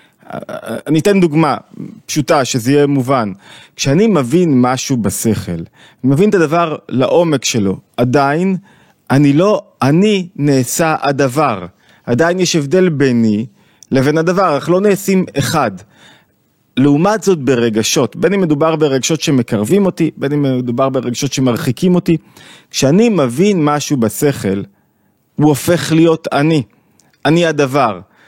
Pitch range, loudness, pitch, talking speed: 130-170 Hz, -13 LUFS, 145 Hz, 125 wpm